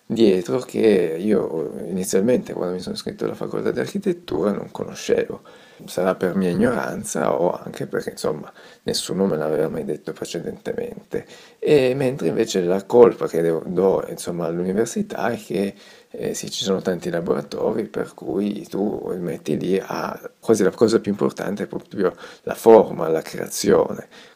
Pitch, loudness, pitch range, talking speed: 95 Hz, -22 LUFS, 90-125 Hz, 155 wpm